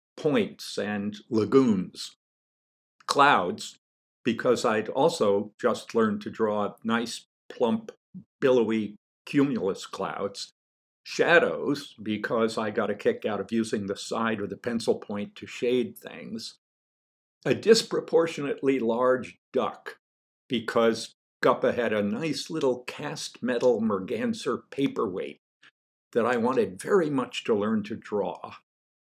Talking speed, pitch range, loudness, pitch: 120 wpm, 105-145 Hz, -27 LUFS, 115 Hz